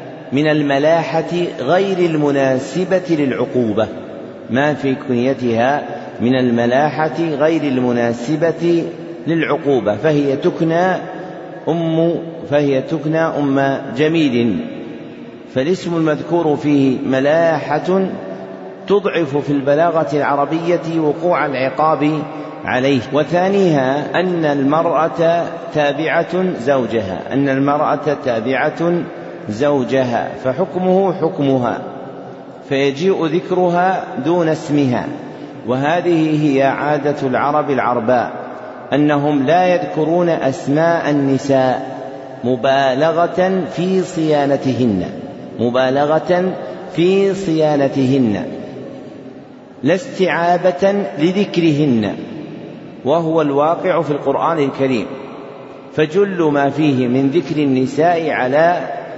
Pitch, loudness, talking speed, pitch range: 150 Hz, -16 LUFS, 80 wpm, 135-170 Hz